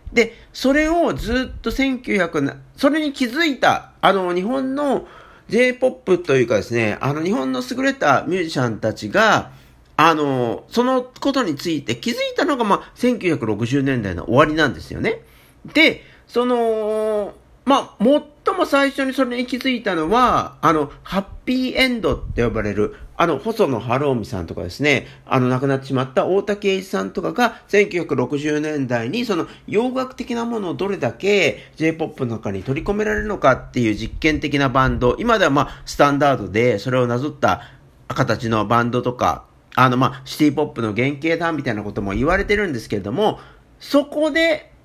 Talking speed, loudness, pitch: 330 characters per minute, -19 LUFS, 160 Hz